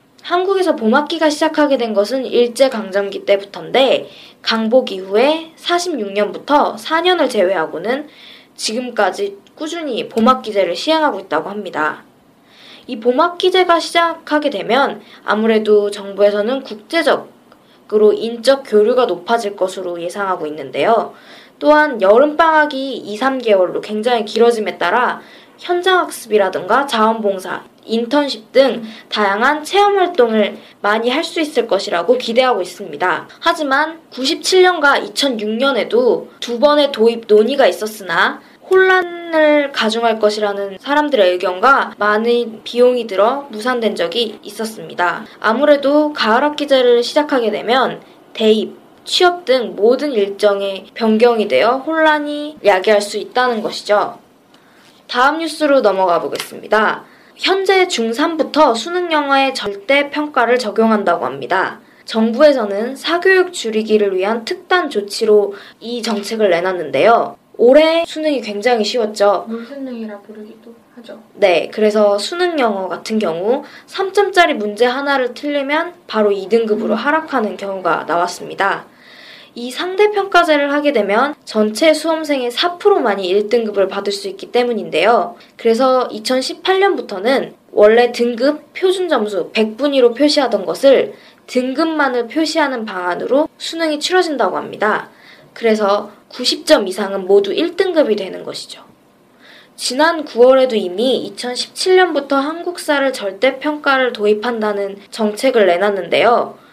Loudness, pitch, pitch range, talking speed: -15 LUFS, 245 Hz, 210-300 Hz, 295 characters per minute